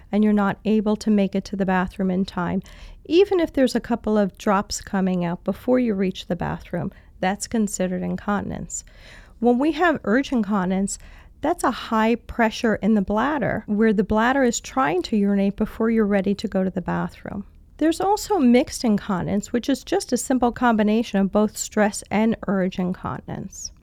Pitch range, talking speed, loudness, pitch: 195-245 Hz, 180 wpm, -22 LUFS, 215 Hz